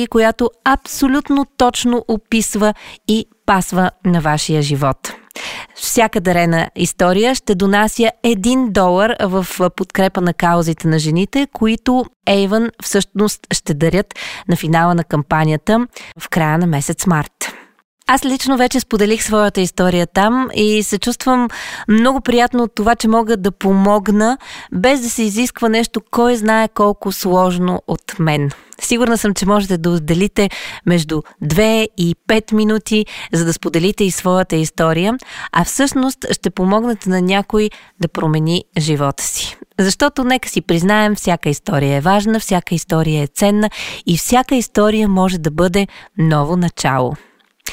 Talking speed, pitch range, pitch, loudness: 140 wpm, 175-225 Hz, 205 Hz, -15 LUFS